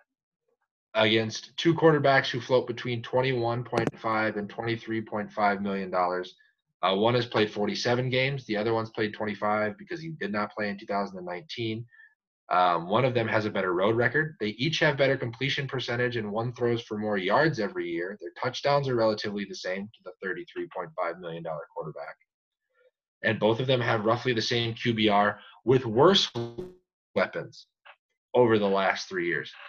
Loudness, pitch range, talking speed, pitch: -27 LUFS, 105-130 Hz, 165 wpm, 115 Hz